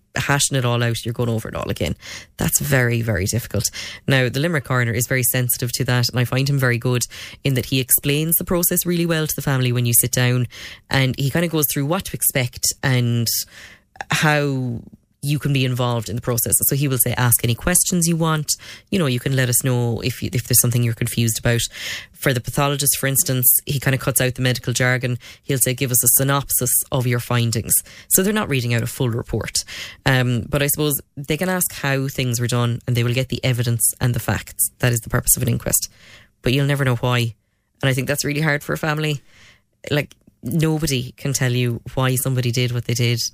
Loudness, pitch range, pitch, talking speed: -19 LUFS, 120-140 Hz, 125 Hz, 235 wpm